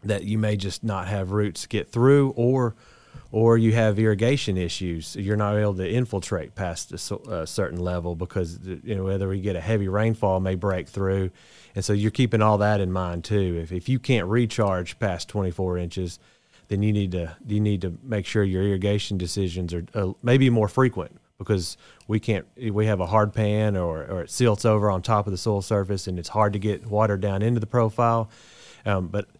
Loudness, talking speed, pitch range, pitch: -24 LUFS, 210 wpm, 95-110 Hz, 105 Hz